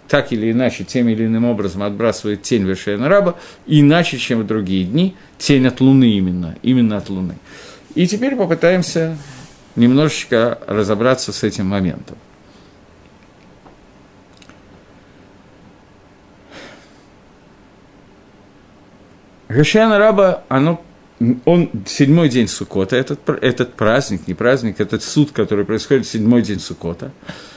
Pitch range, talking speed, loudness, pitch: 105-150 Hz, 105 wpm, -16 LUFS, 120 Hz